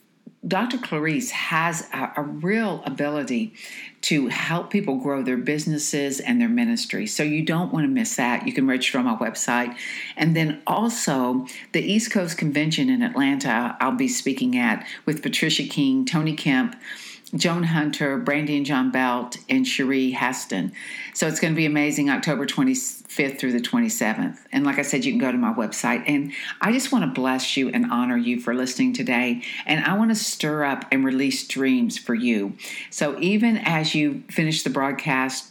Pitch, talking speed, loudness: 170 Hz, 180 wpm, -23 LUFS